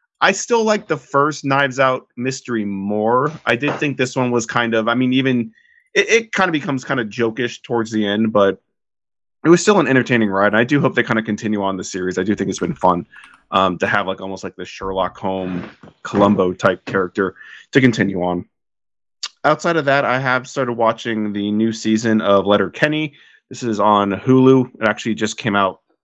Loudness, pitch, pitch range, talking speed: -17 LUFS, 115 Hz, 100-135 Hz, 210 wpm